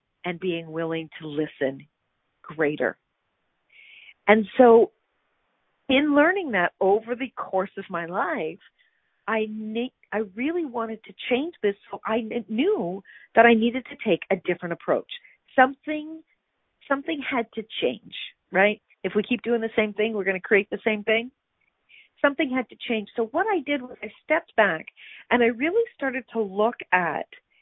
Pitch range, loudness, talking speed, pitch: 200-280 Hz, -24 LUFS, 165 wpm, 230 Hz